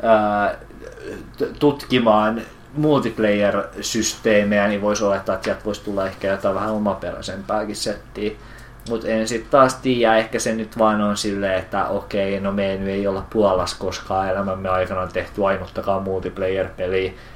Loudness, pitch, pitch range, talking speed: -21 LUFS, 105 Hz, 95-110 Hz, 140 wpm